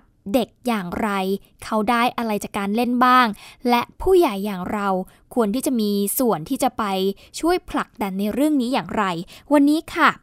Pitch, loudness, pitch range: 230 Hz, -21 LUFS, 200-260 Hz